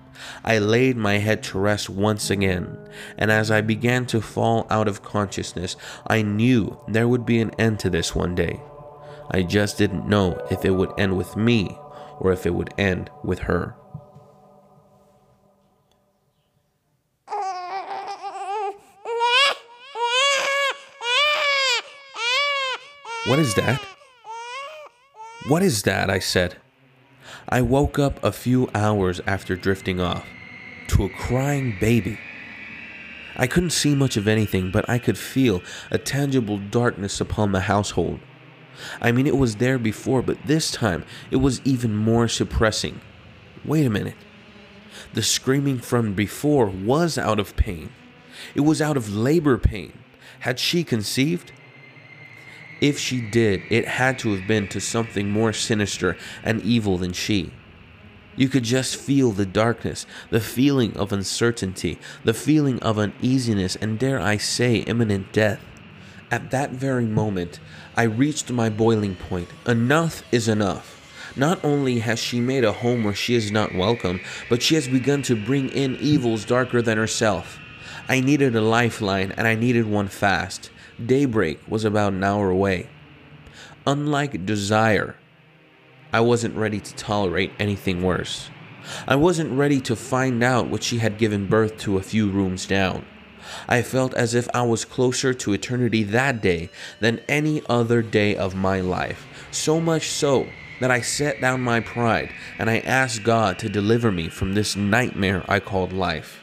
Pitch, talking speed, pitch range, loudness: 115 Hz, 150 wpm, 100-140 Hz, -22 LUFS